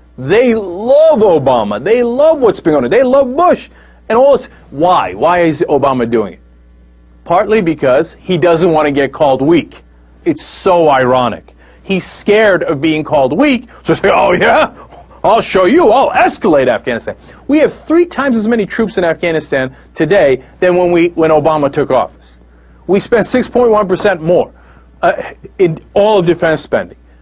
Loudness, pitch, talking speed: -11 LUFS, 170 Hz, 165 wpm